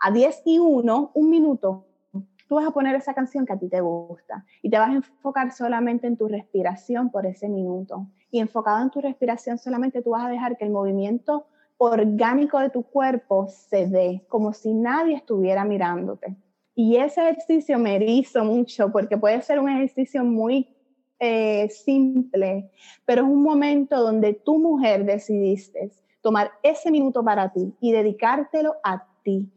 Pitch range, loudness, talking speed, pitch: 200-270 Hz, -22 LUFS, 170 wpm, 235 Hz